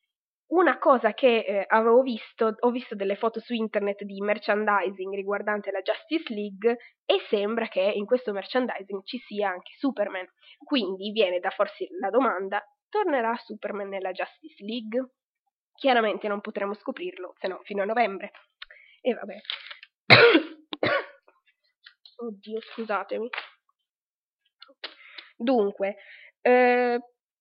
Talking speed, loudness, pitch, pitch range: 120 wpm, -26 LUFS, 225 Hz, 205-260 Hz